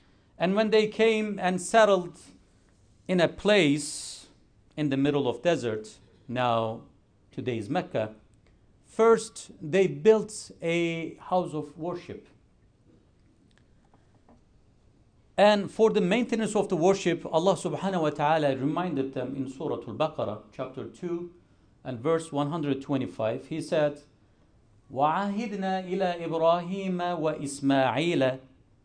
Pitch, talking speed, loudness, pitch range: 155 Hz, 105 wpm, -27 LUFS, 130-185 Hz